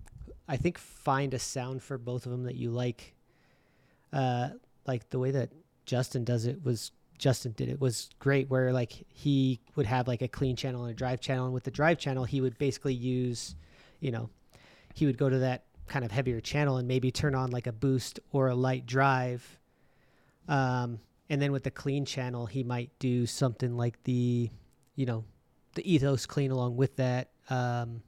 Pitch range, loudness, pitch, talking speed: 125-135 Hz, -31 LUFS, 130 Hz, 195 wpm